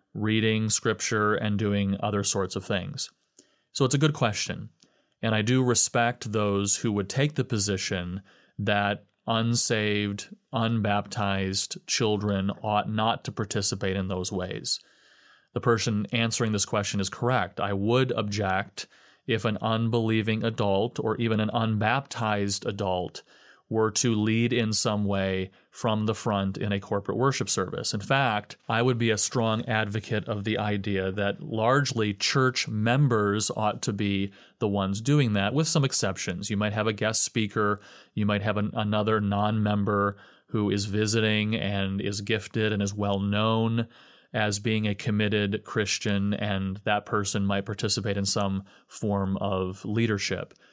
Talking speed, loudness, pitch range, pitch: 155 wpm, -26 LUFS, 100-115 Hz, 105 Hz